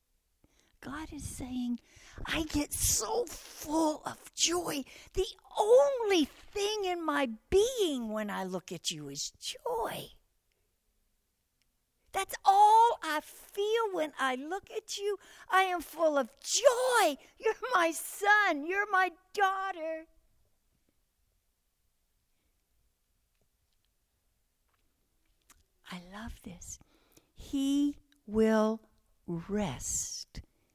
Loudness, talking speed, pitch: -30 LUFS, 95 wpm, 320 Hz